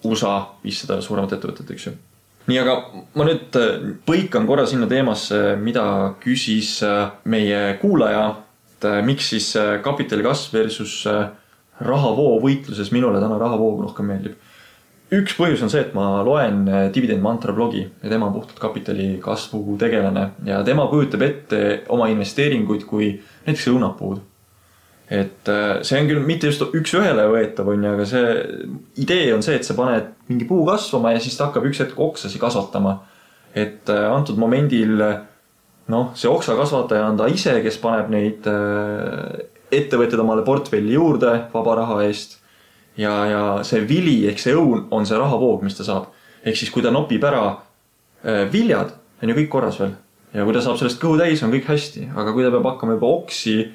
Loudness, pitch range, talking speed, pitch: -19 LUFS, 105-130 Hz, 165 wpm, 110 Hz